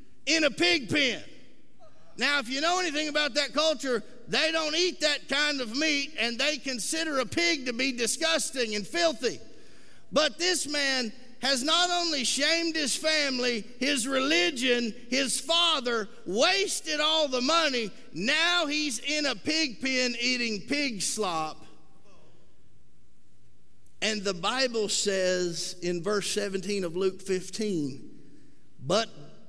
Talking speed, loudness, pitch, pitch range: 135 wpm, -27 LUFS, 270 Hz, 225-310 Hz